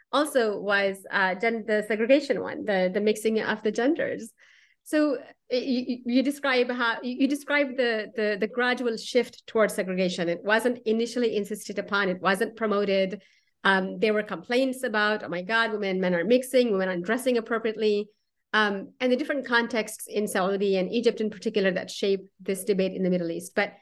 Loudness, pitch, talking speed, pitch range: -26 LUFS, 215 Hz, 180 wpm, 200-245 Hz